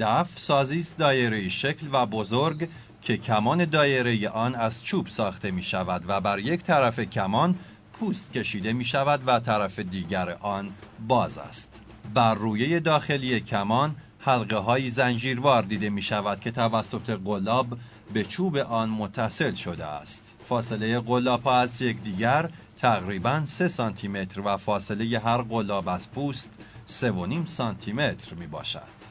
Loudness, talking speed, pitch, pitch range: -26 LUFS, 145 wpm, 115 Hz, 105-130 Hz